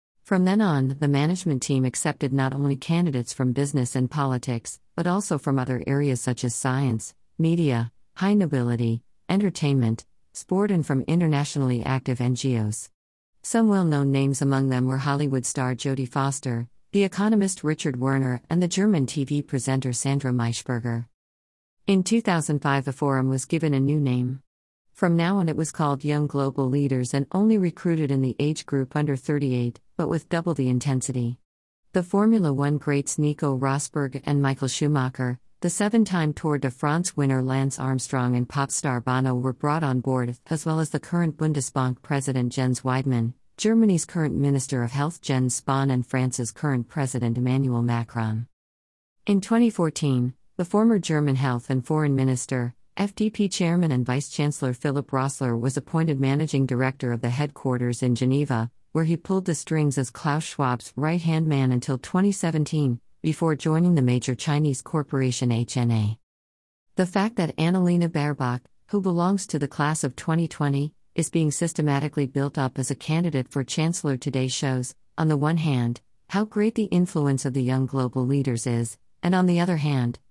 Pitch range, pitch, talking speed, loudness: 125-160 Hz, 140 Hz, 165 wpm, -24 LUFS